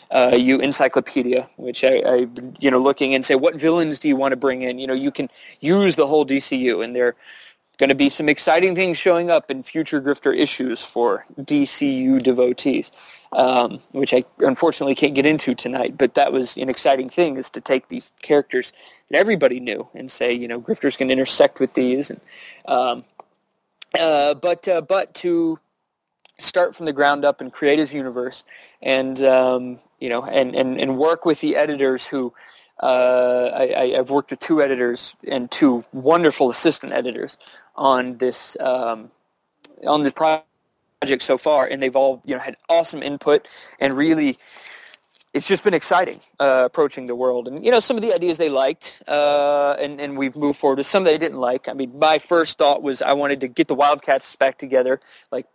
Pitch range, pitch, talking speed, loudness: 130-155 Hz, 140 Hz, 190 wpm, -19 LUFS